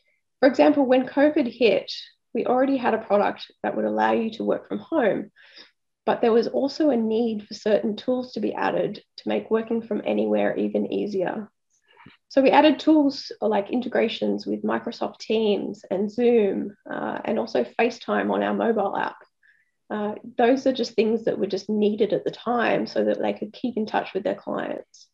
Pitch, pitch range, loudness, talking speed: 220 Hz, 190-255 Hz, -23 LUFS, 185 wpm